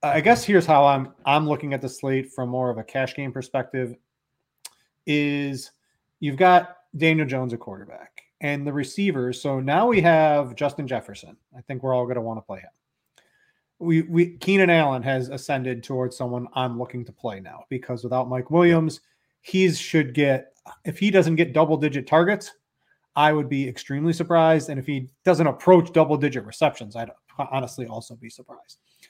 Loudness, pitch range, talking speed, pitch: -22 LUFS, 125-160 Hz, 180 wpm, 140 Hz